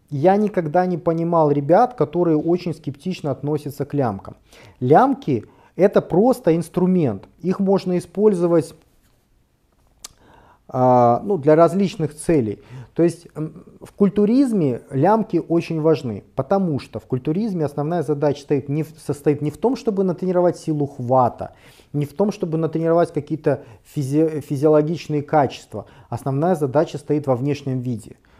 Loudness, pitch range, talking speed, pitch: -20 LUFS, 140-175 Hz, 135 wpm, 155 Hz